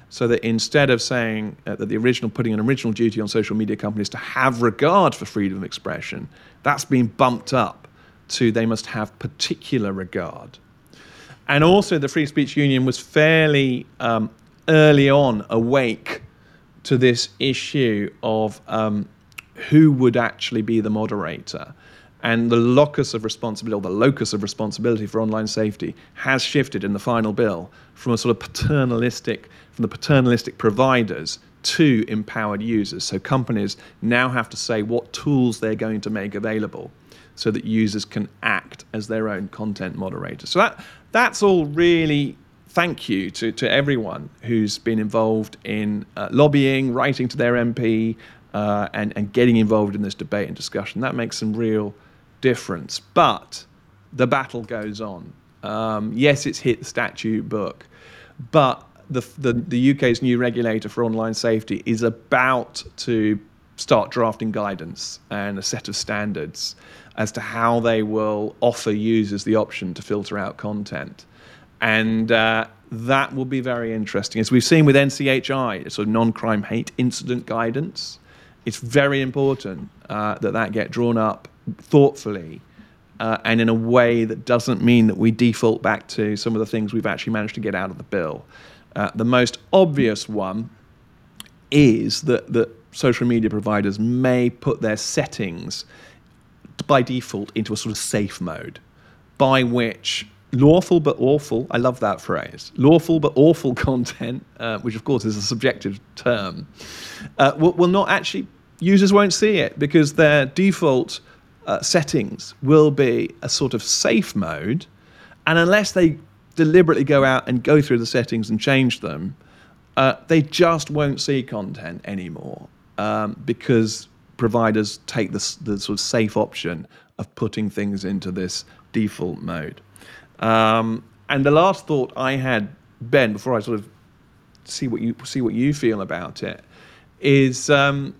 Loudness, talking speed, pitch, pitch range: -20 LUFS, 160 wpm, 115 Hz, 110-135 Hz